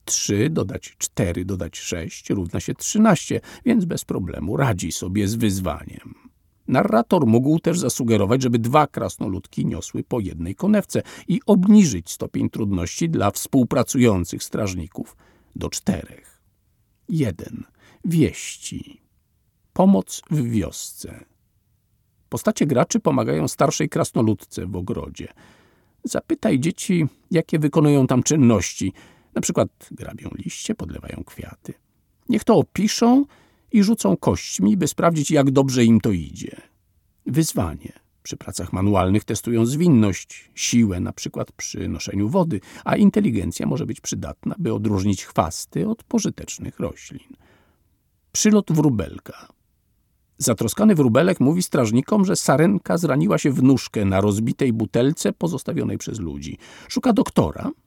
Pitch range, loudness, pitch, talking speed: 100-165 Hz, -21 LUFS, 125 Hz, 120 wpm